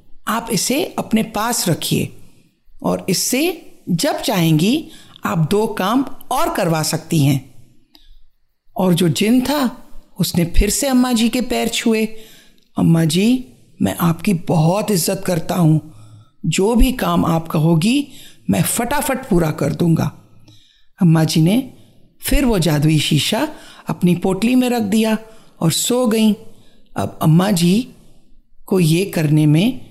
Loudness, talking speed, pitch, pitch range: -17 LUFS, 135 wpm, 190 Hz, 165-235 Hz